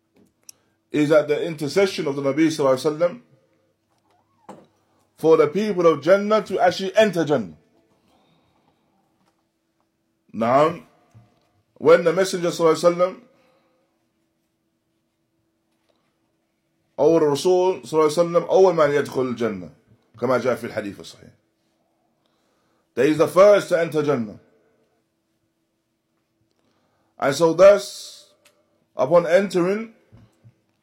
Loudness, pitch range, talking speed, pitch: -19 LUFS, 145-195 Hz, 80 wpm, 175 Hz